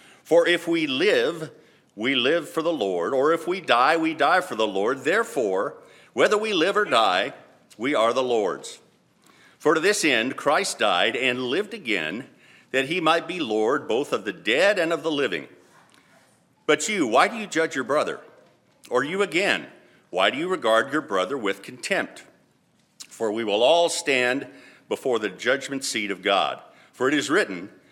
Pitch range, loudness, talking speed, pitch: 125-170 Hz, -23 LUFS, 180 wpm, 155 Hz